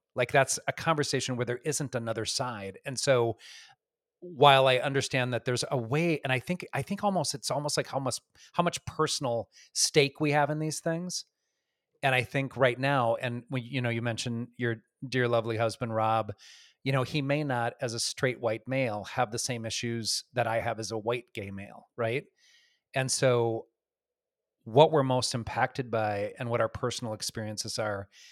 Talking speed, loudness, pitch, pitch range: 190 wpm, -29 LUFS, 125 Hz, 115-145 Hz